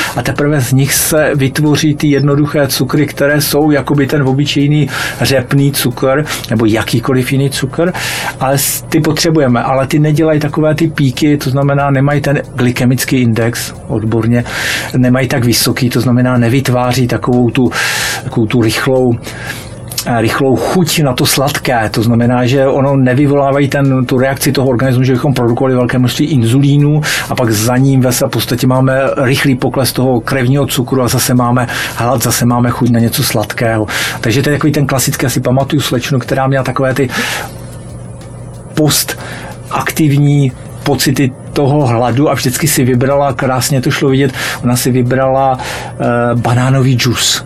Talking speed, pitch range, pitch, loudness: 155 wpm, 125-140 Hz, 130 Hz, -11 LUFS